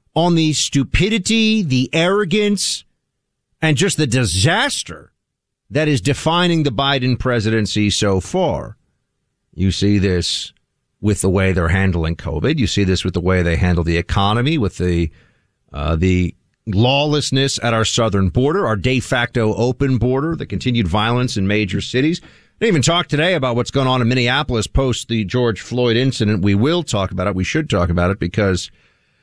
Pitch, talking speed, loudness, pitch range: 120 Hz, 170 wpm, -17 LUFS, 95-140 Hz